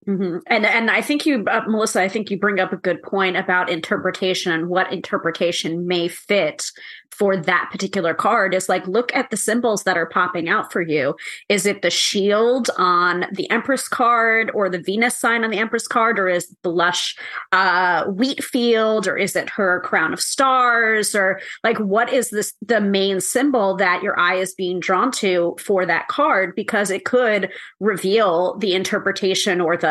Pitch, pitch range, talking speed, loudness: 195 Hz, 185-225 Hz, 195 wpm, -19 LUFS